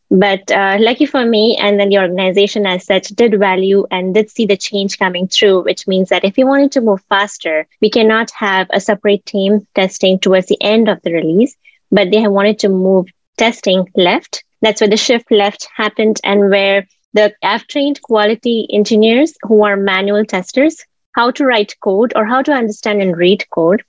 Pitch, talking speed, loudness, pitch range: 205 Hz, 195 wpm, -12 LUFS, 195-225 Hz